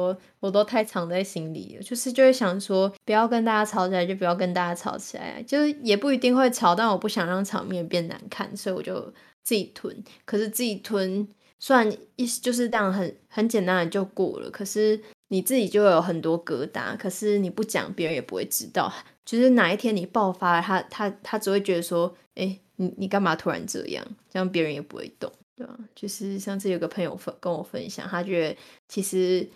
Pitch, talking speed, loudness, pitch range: 195 Hz, 315 characters per minute, -25 LUFS, 185-220 Hz